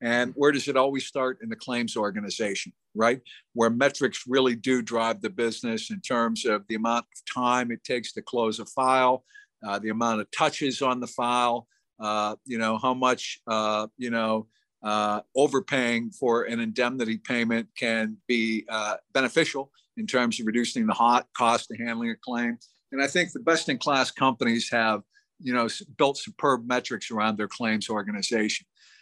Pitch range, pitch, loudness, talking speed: 115-130 Hz, 120 Hz, -26 LUFS, 175 wpm